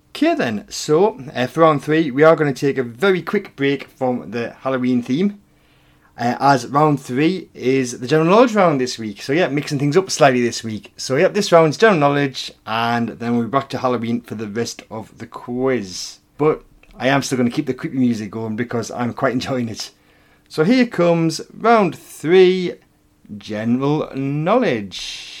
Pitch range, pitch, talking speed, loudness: 120-160 Hz, 135 Hz, 190 wpm, -18 LUFS